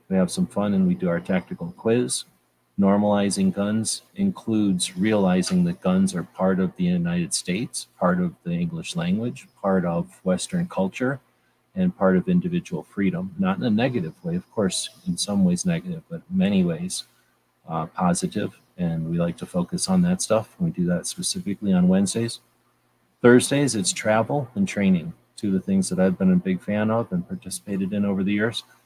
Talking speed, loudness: 185 wpm, -23 LUFS